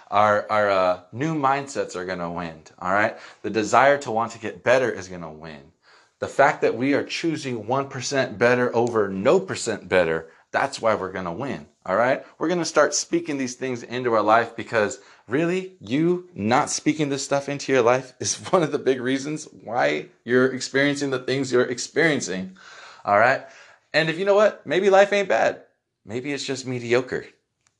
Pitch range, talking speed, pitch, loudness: 110-145 Hz, 185 wpm, 130 Hz, -22 LUFS